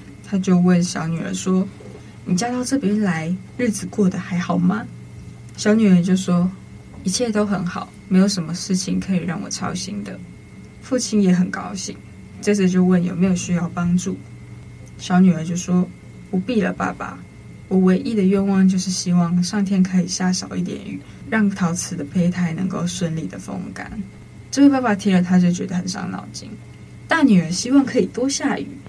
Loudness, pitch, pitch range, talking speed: -20 LUFS, 185 Hz, 180-200 Hz, 260 characters per minute